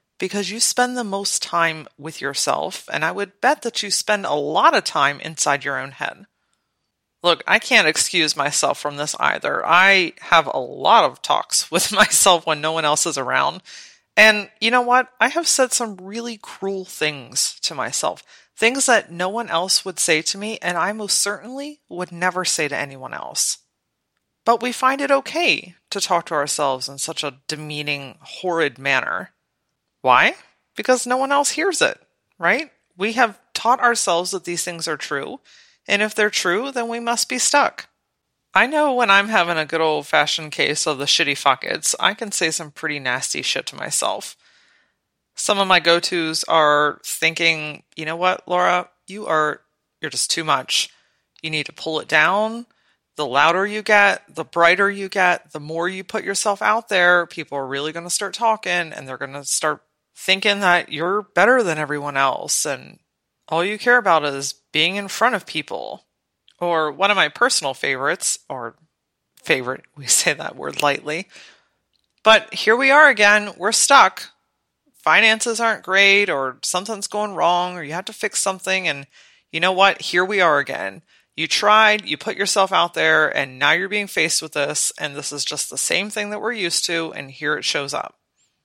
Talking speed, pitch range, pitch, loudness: 185 wpm, 155-215 Hz, 180 Hz, -18 LUFS